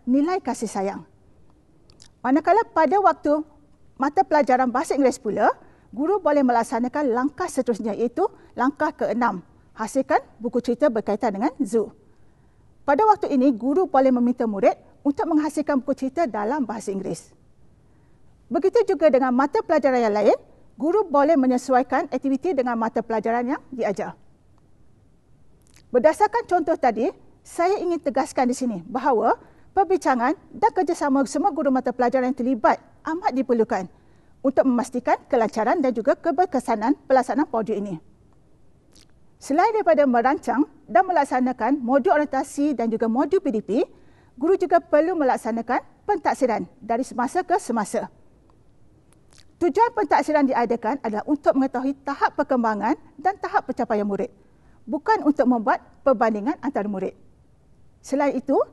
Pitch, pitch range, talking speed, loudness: 275 Hz, 240-320 Hz, 125 wpm, -22 LUFS